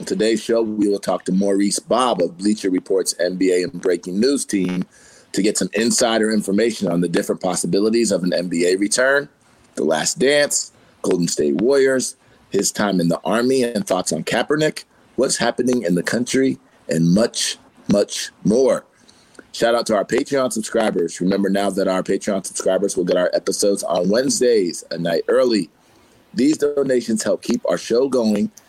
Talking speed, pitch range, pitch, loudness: 170 wpm, 95-125 Hz, 105 Hz, -19 LUFS